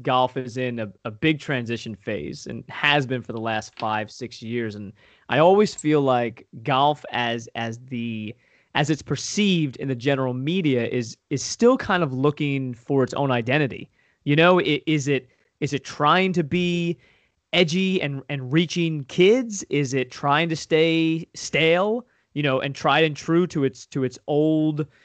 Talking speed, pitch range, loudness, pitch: 180 wpm, 125-160 Hz, -22 LUFS, 145 Hz